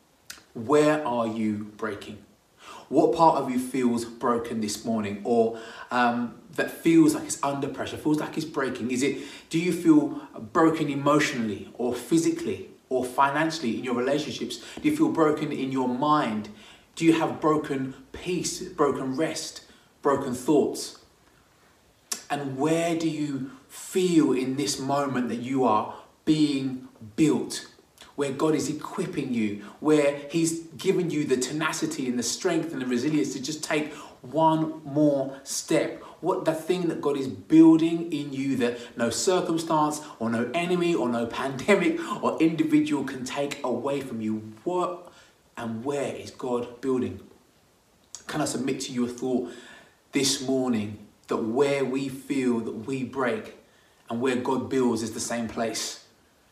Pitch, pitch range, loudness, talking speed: 135 Hz, 120-155 Hz, -26 LUFS, 155 wpm